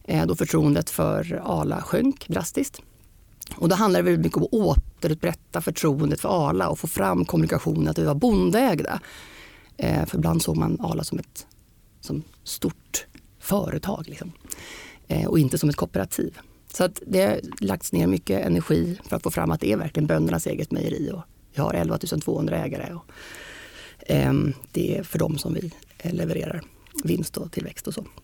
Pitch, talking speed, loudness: 160 Hz, 170 wpm, -24 LUFS